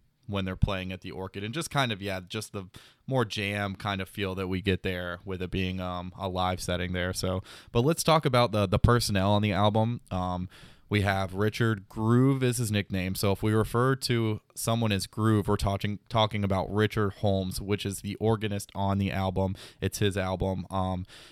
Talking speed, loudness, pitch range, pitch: 210 wpm, -28 LUFS, 95-110 Hz, 100 Hz